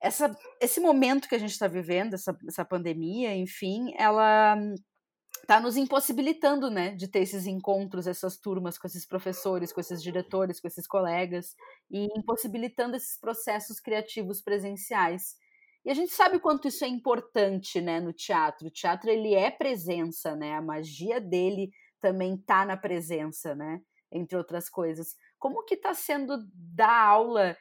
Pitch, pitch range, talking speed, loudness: 195 Hz, 180-240 Hz, 155 wpm, -28 LUFS